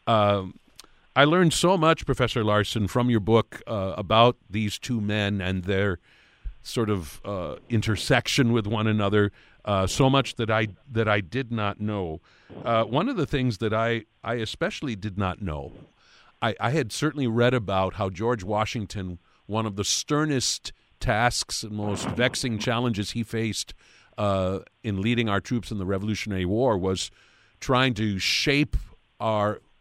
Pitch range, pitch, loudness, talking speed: 100-120 Hz, 110 Hz, -25 LUFS, 160 wpm